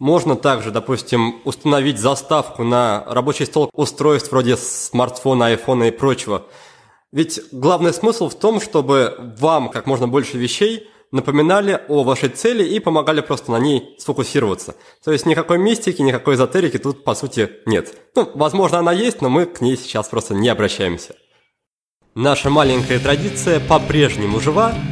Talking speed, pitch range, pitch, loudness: 150 wpm, 125-155 Hz, 140 Hz, -17 LUFS